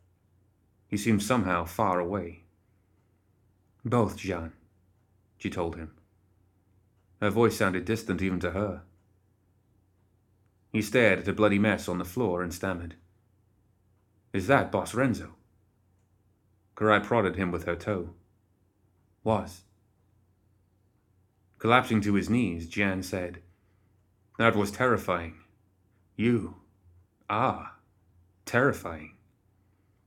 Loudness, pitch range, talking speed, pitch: -28 LUFS, 95-105 Hz, 100 wpm, 95 Hz